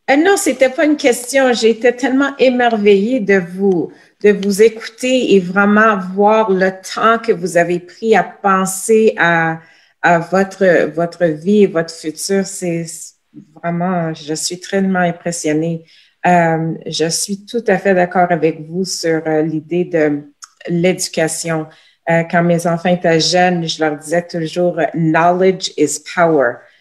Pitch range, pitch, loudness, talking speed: 165-205 Hz, 180 Hz, -14 LUFS, 150 wpm